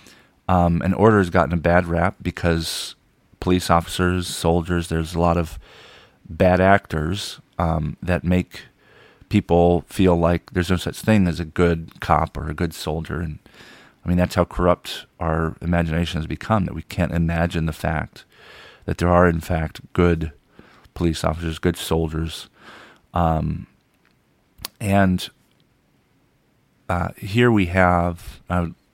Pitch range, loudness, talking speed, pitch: 80-90 Hz, -21 LUFS, 145 wpm, 85 Hz